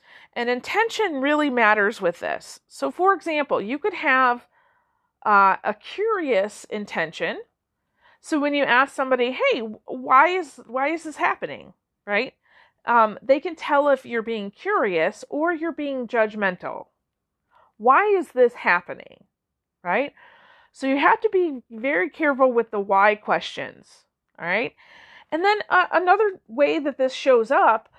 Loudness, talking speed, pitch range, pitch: -21 LUFS, 145 wpm, 235-375 Hz, 285 Hz